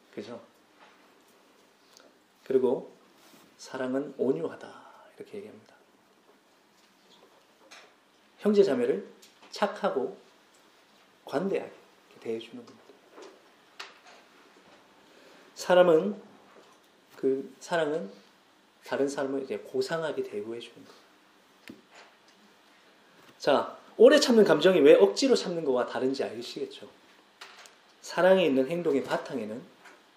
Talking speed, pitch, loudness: 205 characters per minute, 185 Hz, -26 LUFS